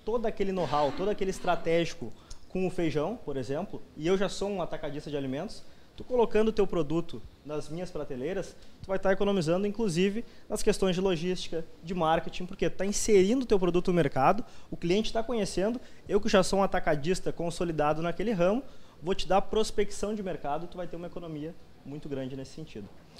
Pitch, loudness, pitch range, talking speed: 180 Hz, -30 LUFS, 155-200 Hz, 195 wpm